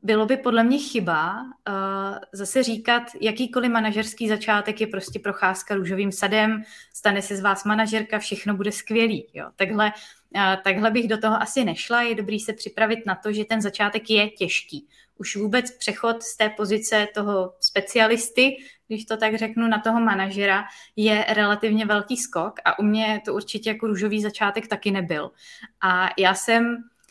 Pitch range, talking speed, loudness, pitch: 200-225 Hz, 170 wpm, -23 LUFS, 215 Hz